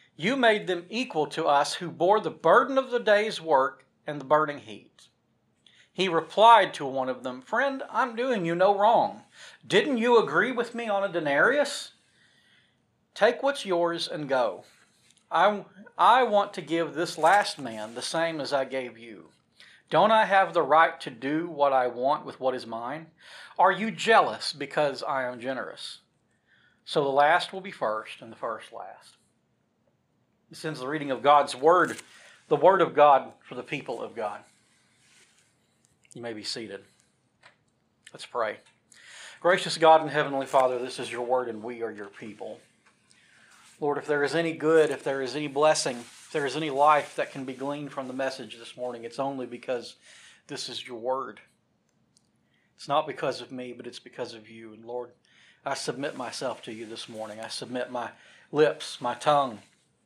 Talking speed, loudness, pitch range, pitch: 180 wpm, -26 LUFS, 125-175 Hz, 145 Hz